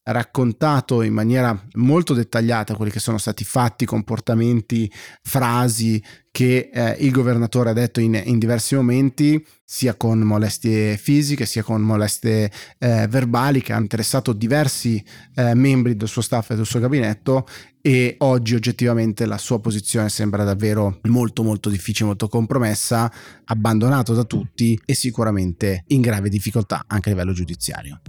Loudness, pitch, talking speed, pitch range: -19 LUFS, 115 Hz, 145 wpm, 110-125 Hz